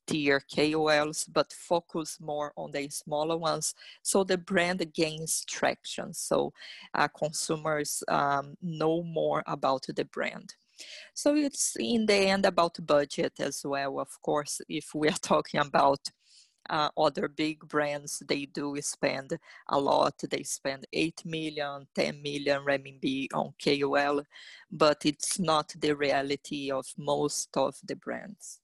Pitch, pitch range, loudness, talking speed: 150 Hz, 145-170 Hz, -30 LUFS, 140 wpm